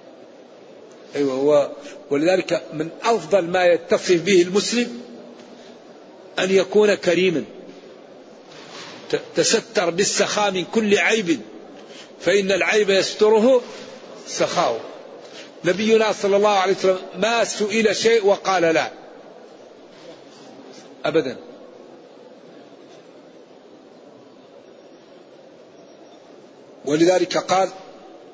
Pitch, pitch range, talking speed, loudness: 200 Hz, 180-225 Hz, 70 wpm, -19 LUFS